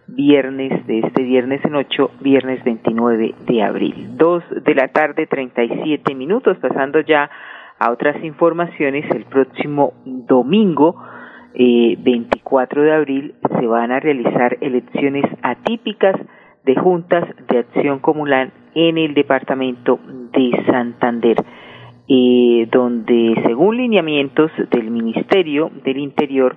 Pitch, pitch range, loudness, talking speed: 135 Hz, 125-150 Hz, -16 LUFS, 115 wpm